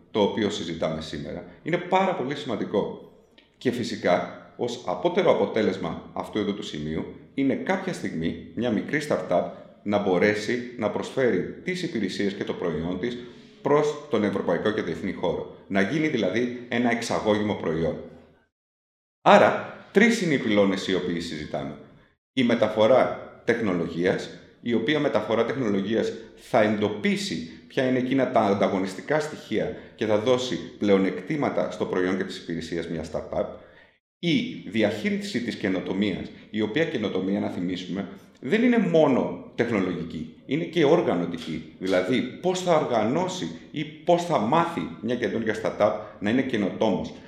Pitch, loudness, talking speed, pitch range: 110 Hz, -25 LUFS, 135 wpm, 95-150 Hz